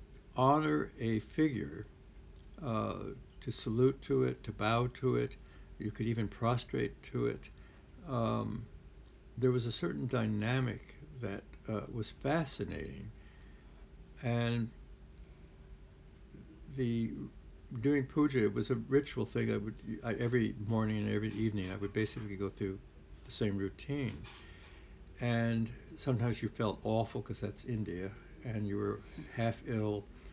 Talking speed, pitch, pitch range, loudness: 130 wpm, 110 Hz, 95-120 Hz, -36 LUFS